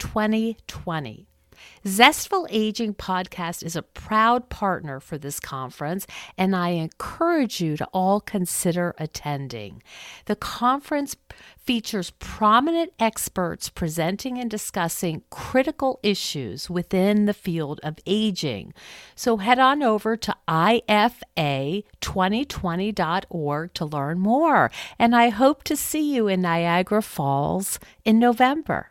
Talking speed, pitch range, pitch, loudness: 115 wpm, 165-230 Hz, 195 Hz, -23 LUFS